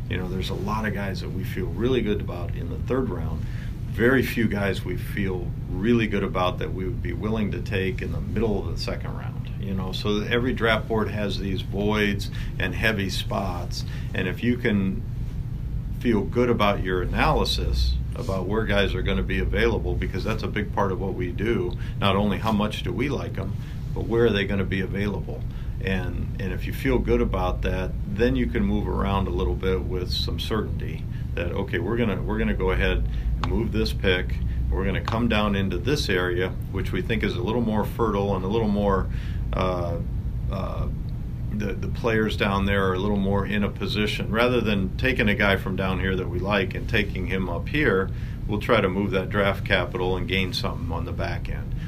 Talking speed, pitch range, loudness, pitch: 220 wpm, 95-120 Hz, -25 LUFS, 105 Hz